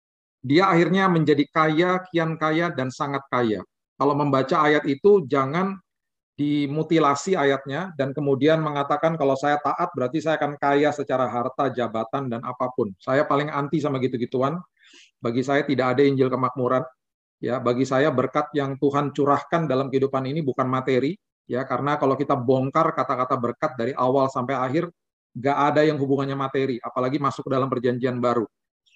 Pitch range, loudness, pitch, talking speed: 130-150 Hz, -23 LUFS, 140 Hz, 155 wpm